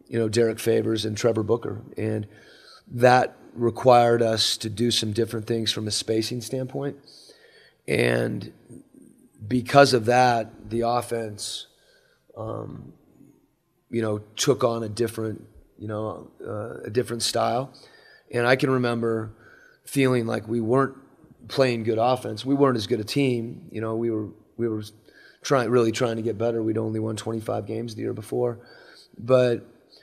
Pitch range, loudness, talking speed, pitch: 110-125 Hz, -24 LUFS, 155 wpm, 115 Hz